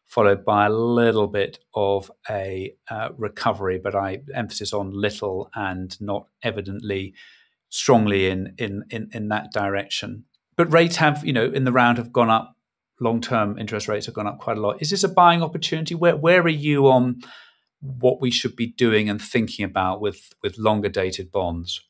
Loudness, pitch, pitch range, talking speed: -22 LUFS, 110 Hz, 100-125 Hz, 185 wpm